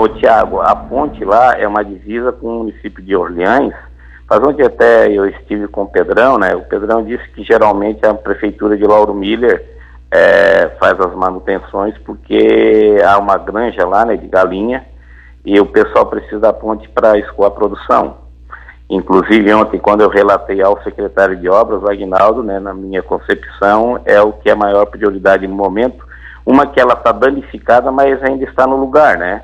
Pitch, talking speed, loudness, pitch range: 100 Hz, 175 wpm, -12 LUFS, 95-110 Hz